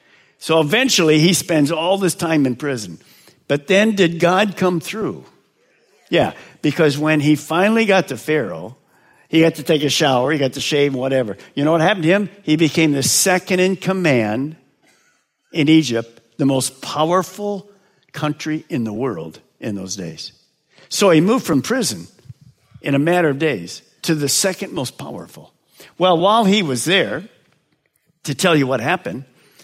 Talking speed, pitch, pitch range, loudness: 170 wpm, 160 Hz, 140-185 Hz, -17 LUFS